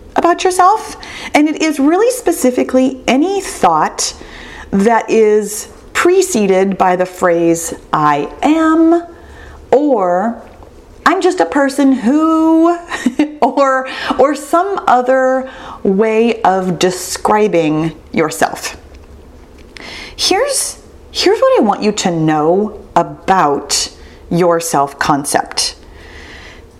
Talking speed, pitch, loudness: 95 wpm, 250 Hz, -13 LUFS